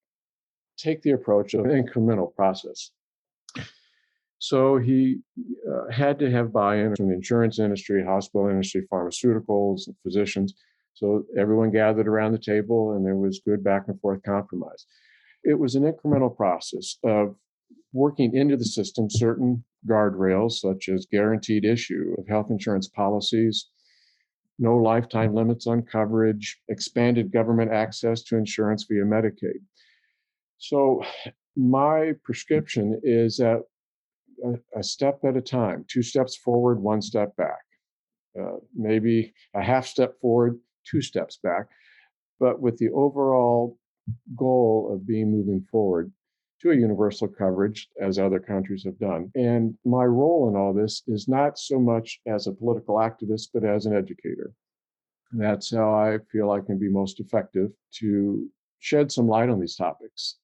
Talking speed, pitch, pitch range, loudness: 145 wpm, 110 Hz, 105-125 Hz, -24 LUFS